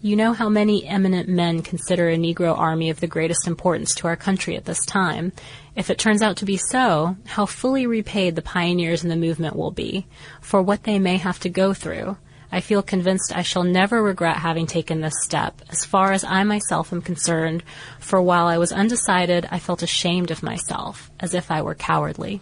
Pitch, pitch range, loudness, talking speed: 180 Hz, 165-195 Hz, -21 LUFS, 210 wpm